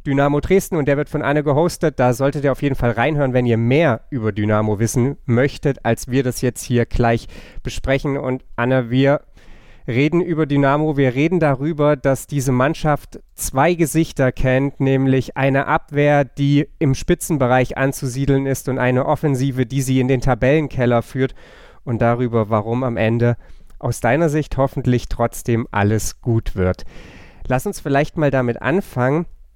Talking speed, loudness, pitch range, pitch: 160 wpm, -18 LUFS, 120-145 Hz, 135 Hz